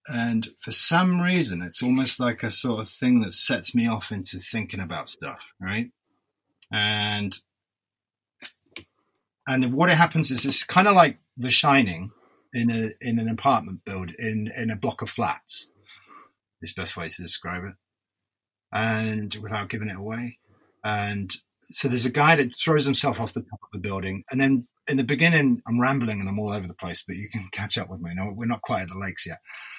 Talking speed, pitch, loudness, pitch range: 195 wpm, 110 Hz, -23 LUFS, 100-125 Hz